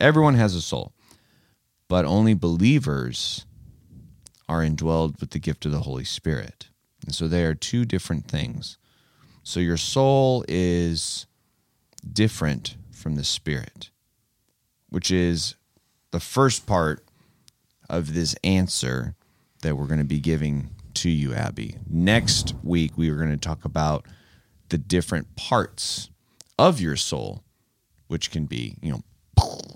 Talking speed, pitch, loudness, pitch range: 135 wpm, 85 Hz, -24 LUFS, 75-110 Hz